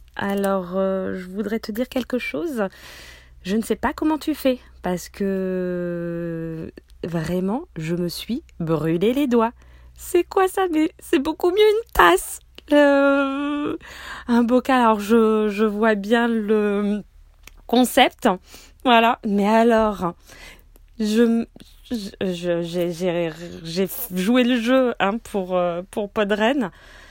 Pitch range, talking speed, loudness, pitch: 185-255 Hz, 130 wpm, -21 LUFS, 220 Hz